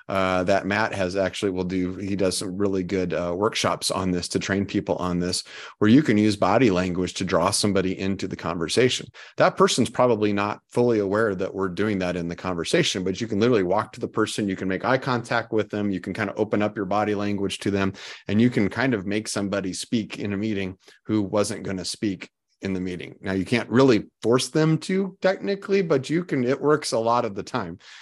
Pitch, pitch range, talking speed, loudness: 100 Hz, 95-115 Hz, 235 wpm, -24 LUFS